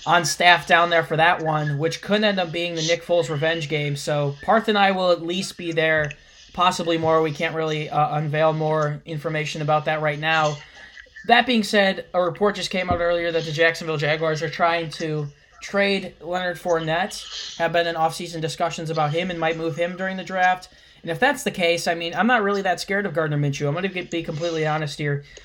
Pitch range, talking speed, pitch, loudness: 155-180 Hz, 220 wpm, 165 Hz, -22 LUFS